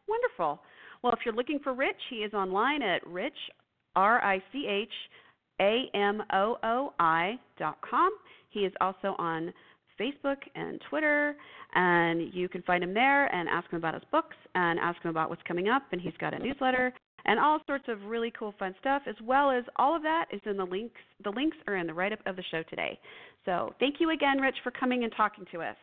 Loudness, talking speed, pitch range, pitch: -30 LUFS, 195 wpm, 185-275 Hz, 215 Hz